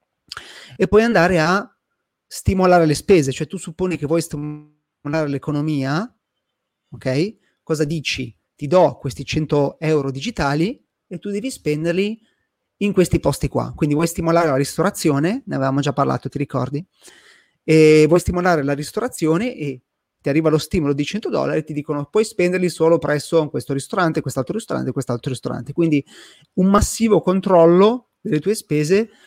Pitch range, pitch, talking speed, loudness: 145-185 Hz, 160 Hz, 155 wpm, -19 LUFS